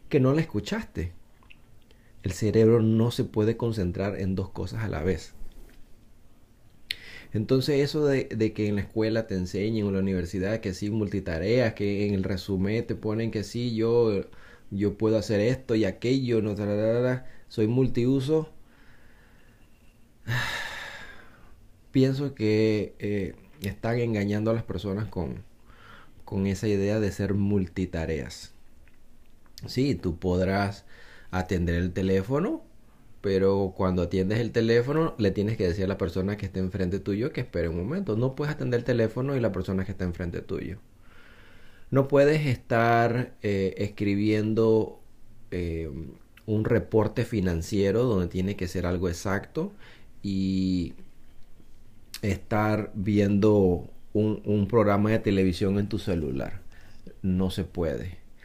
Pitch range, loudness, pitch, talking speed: 95-115 Hz, -27 LUFS, 105 Hz, 140 wpm